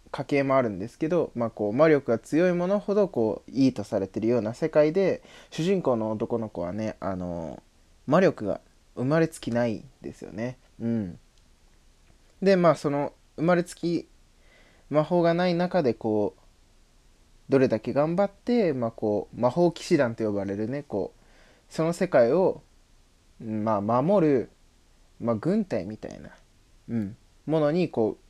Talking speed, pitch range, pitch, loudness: 285 characters per minute, 105-160 Hz, 120 Hz, -26 LUFS